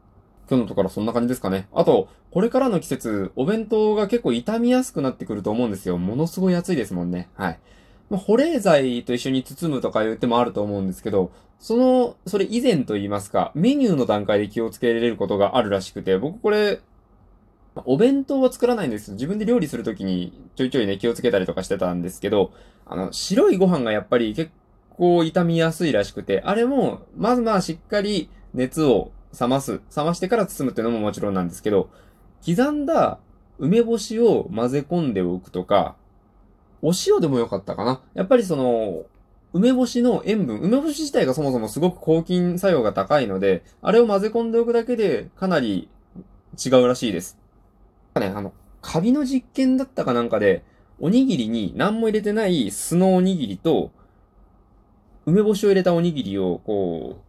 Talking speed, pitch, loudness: 385 characters per minute, 130 Hz, -21 LUFS